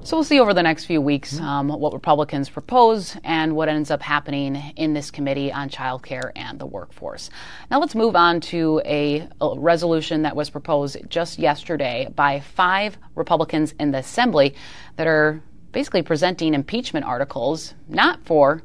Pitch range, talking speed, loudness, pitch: 145-170 Hz, 170 wpm, -21 LUFS, 155 Hz